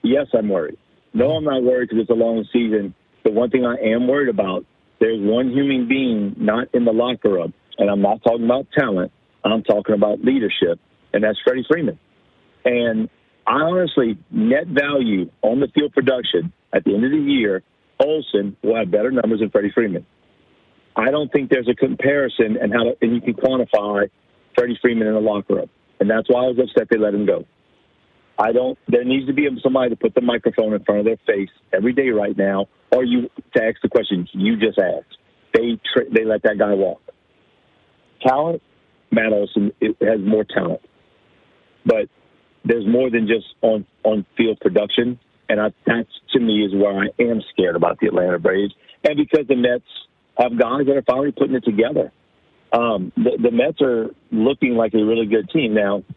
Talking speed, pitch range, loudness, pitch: 195 wpm, 105-130 Hz, -19 LUFS, 115 Hz